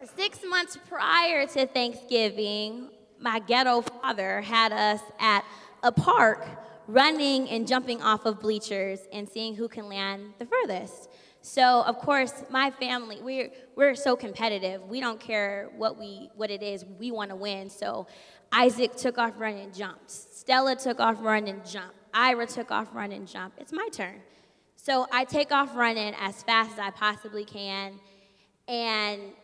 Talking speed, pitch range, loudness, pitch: 165 wpm, 205-255 Hz, -27 LUFS, 225 Hz